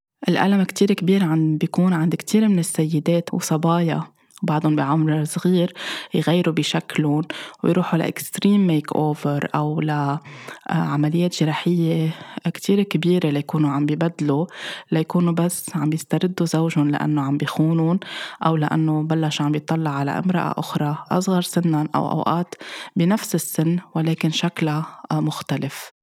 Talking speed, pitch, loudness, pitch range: 120 wpm, 160 Hz, -21 LUFS, 155-175 Hz